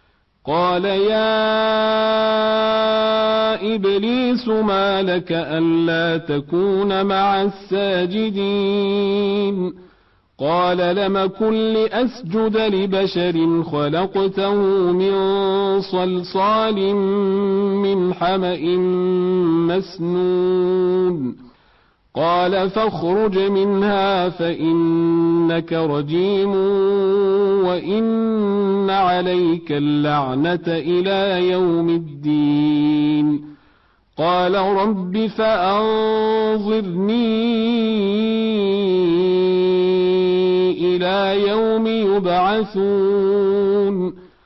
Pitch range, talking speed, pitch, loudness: 180-200 Hz, 50 wpm, 195 Hz, -18 LUFS